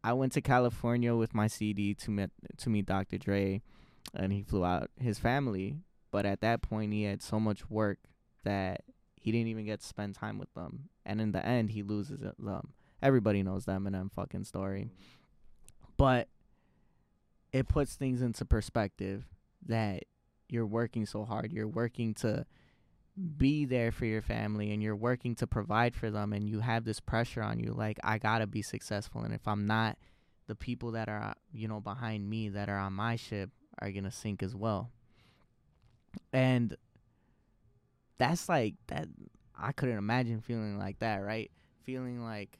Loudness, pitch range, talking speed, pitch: -34 LUFS, 100-120 Hz, 180 wpm, 110 Hz